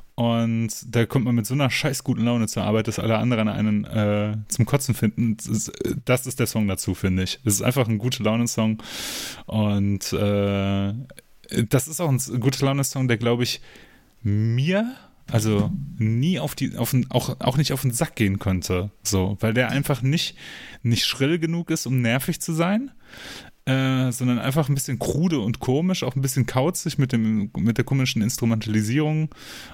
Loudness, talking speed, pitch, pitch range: -23 LUFS, 190 wpm, 120 Hz, 110-135 Hz